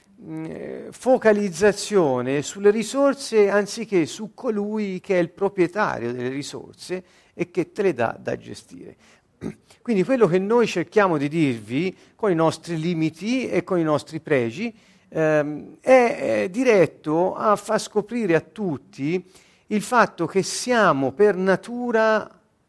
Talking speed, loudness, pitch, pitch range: 125 wpm, -22 LUFS, 190 Hz, 160-215 Hz